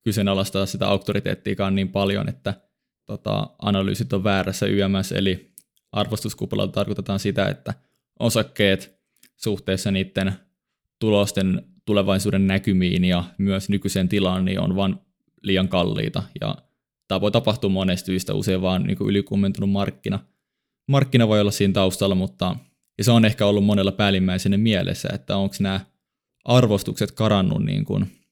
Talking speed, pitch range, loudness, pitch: 135 wpm, 95-100 Hz, -22 LUFS, 100 Hz